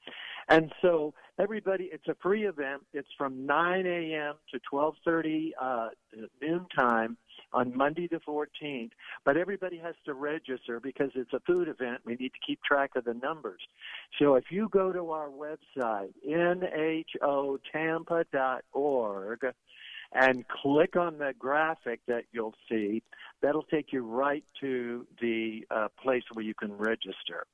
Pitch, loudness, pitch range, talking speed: 145 Hz, -31 LUFS, 125-160 Hz, 140 wpm